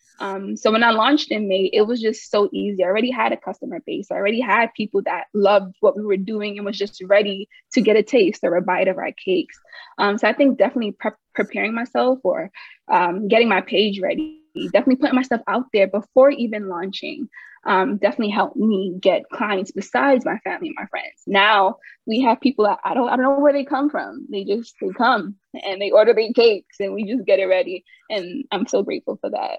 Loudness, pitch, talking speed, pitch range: -19 LUFS, 215 Hz, 225 wpm, 200-255 Hz